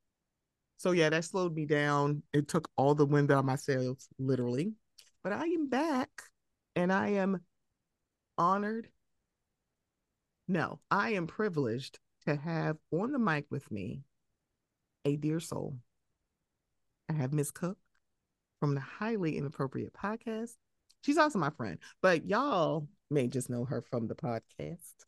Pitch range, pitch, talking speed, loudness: 140-195 Hz, 155 Hz, 145 wpm, -33 LUFS